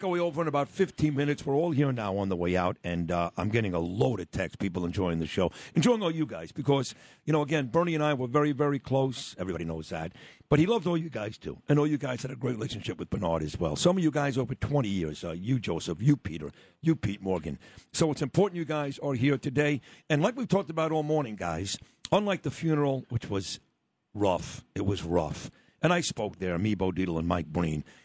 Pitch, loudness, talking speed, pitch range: 130 Hz, -29 LUFS, 240 wpm, 95-150 Hz